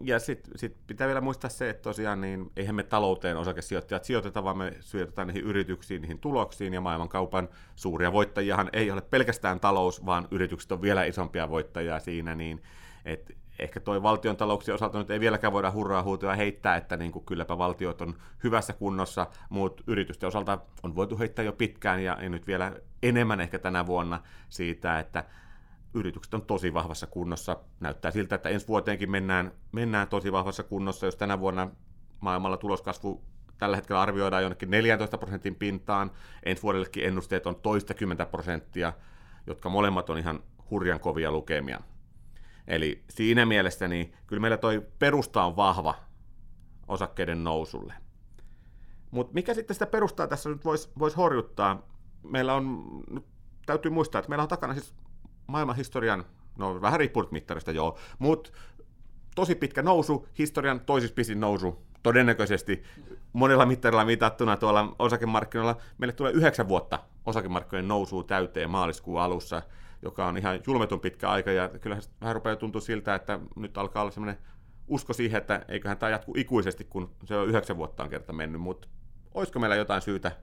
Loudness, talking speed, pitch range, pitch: -29 LUFS, 155 wpm, 90-115 Hz, 100 Hz